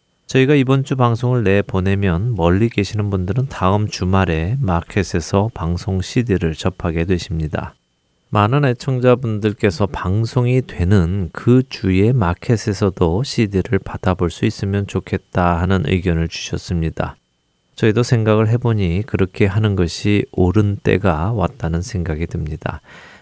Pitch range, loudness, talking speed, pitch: 90-115 Hz, -18 LUFS, 300 characters per minute, 100 Hz